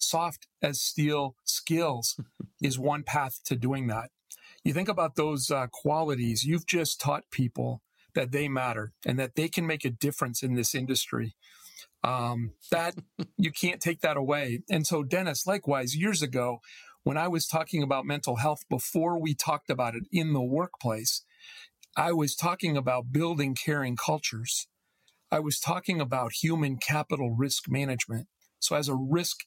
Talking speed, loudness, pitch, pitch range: 165 wpm, -29 LUFS, 145 Hz, 130-165 Hz